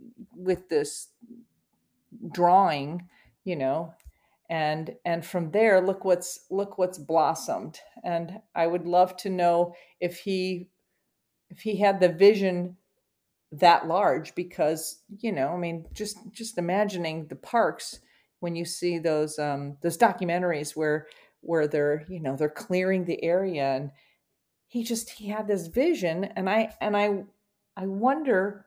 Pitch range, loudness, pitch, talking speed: 165-200 Hz, -26 LUFS, 180 Hz, 140 wpm